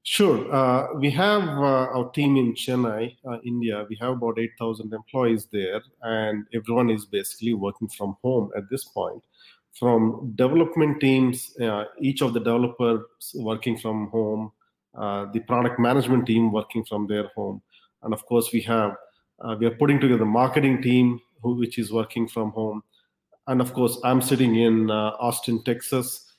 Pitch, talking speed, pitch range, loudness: 120 Hz, 170 wpm, 110-125 Hz, -24 LUFS